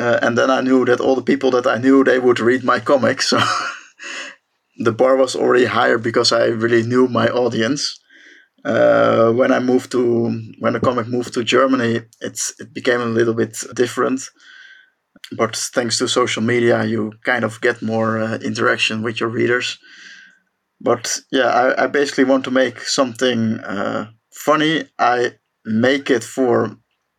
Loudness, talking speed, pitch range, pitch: -17 LUFS, 170 wpm, 115-135 Hz, 125 Hz